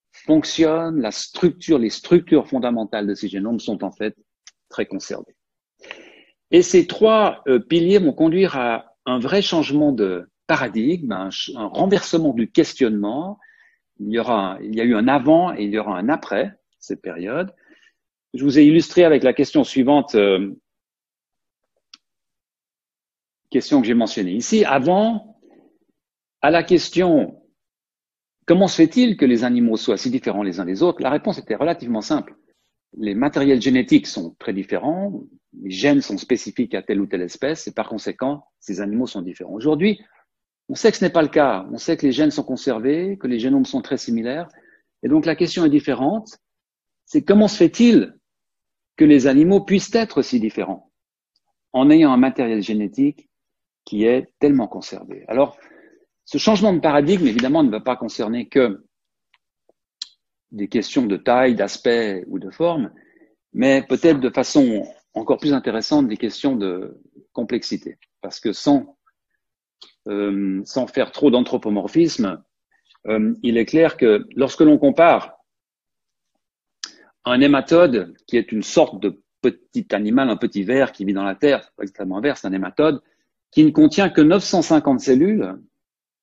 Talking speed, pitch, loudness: 160 wpm, 155 Hz, -18 LUFS